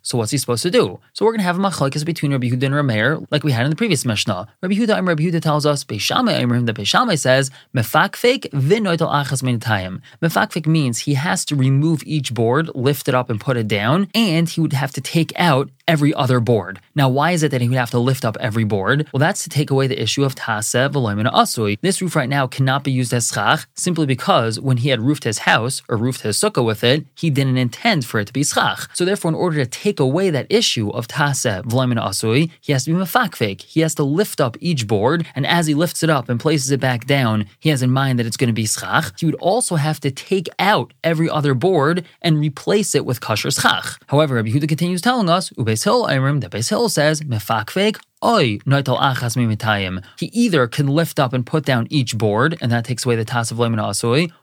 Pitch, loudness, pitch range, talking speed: 140 Hz, -18 LUFS, 120-160 Hz, 230 wpm